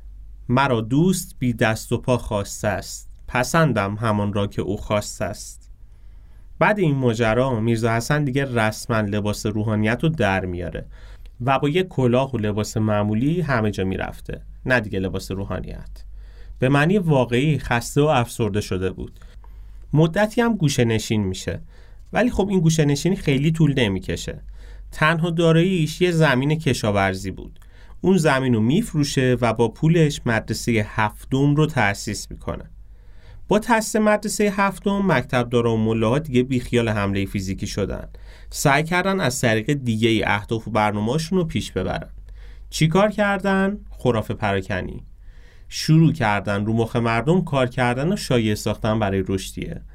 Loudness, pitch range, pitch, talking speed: -21 LUFS, 100-150 Hz, 115 Hz, 145 wpm